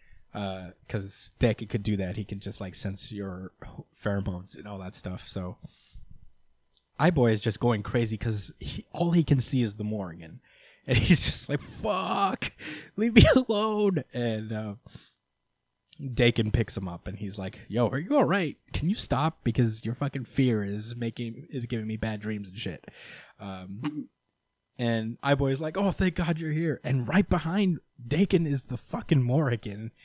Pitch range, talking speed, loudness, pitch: 105-145 Hz, 180 wpm, -28 LUFS, 120 Hz